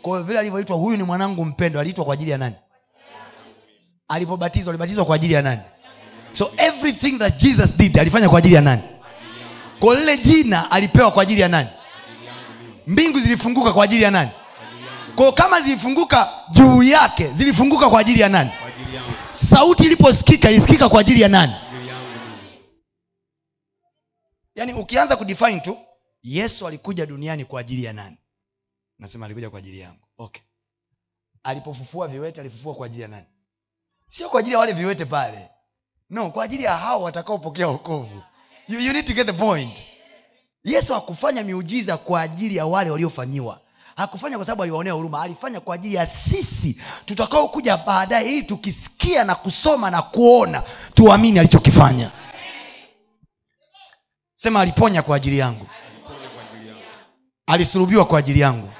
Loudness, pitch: -16 LUFS, 170 Hz